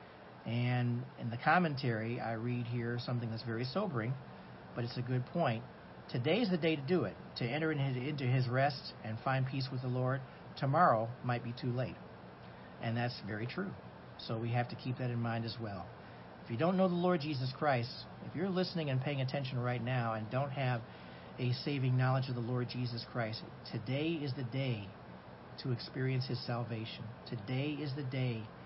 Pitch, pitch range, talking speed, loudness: 125 Hz, 115-135 Hz, 195 wpm, -36 LUFS